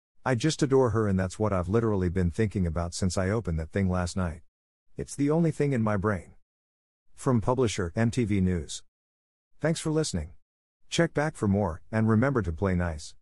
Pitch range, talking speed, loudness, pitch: 85-120 Hz, 190 wpm, -27 LUFS, 100 Hz